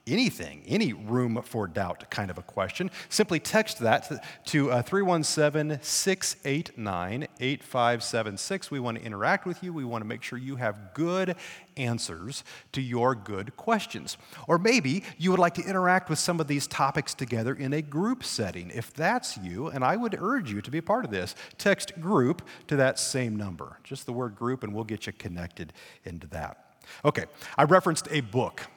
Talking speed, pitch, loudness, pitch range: 185 wpm, 135 Hz, -28 LUFS, 115-175 Hz